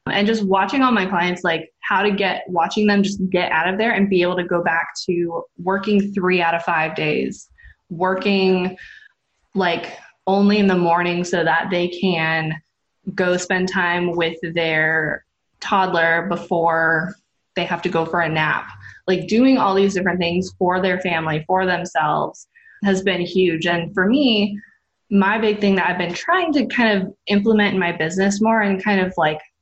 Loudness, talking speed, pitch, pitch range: -19 LUFS, 180 wpm, 185 Hz, 170-200 Hz